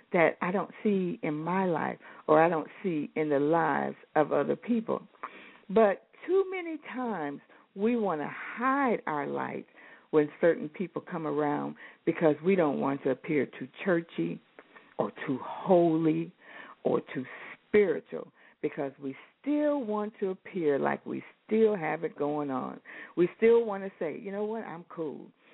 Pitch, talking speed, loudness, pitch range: 180 Hz, 160 wpm, -30 LUFS, 155-225 Hz